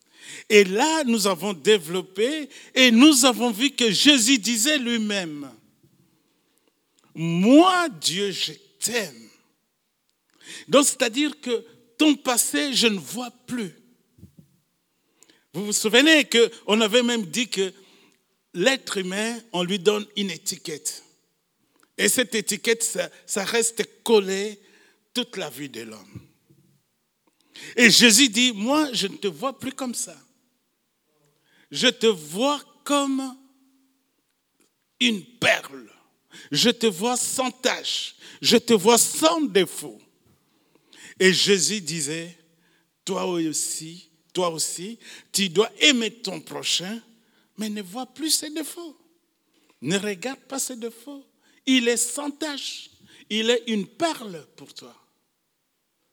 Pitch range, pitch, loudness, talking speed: 195-265 Hz, 230 Hz, -21 LUFS, 125 wpm